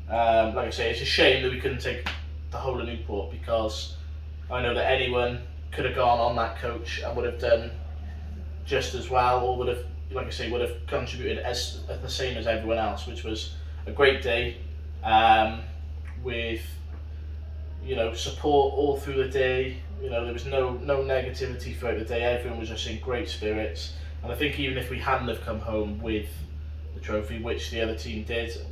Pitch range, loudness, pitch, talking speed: 75-115 Hz, -27 LUFS, 80 Hz, 205 wpm